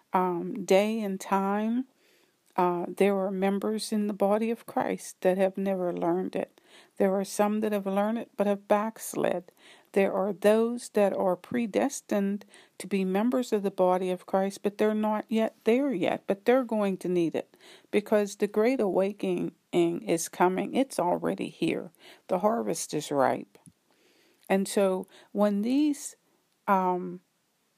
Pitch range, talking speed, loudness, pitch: 190-220 Hz, 155 wpm, -28 LUFS, 200 Hz